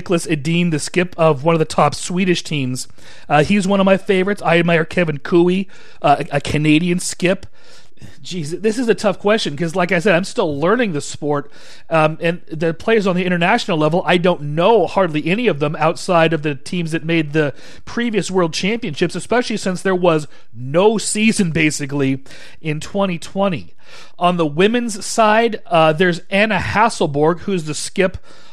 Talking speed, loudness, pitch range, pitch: 180 wpm, -17 LUFS, 155-195 Hz, 175 Hz